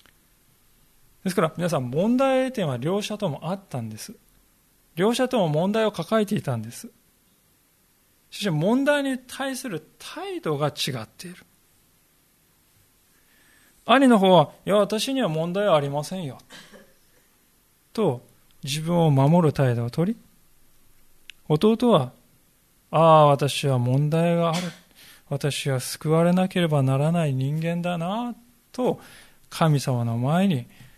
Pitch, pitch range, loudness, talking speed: 170 Hz, 140-205 Hz, -23 LUFS, 225 characters per minute